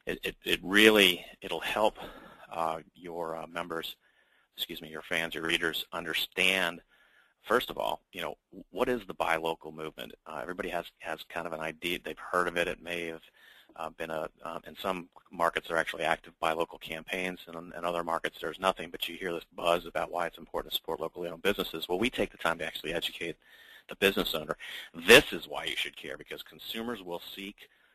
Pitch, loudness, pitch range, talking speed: 85 Hz, -30 LUFS, 80-95 Hz, 210 wpm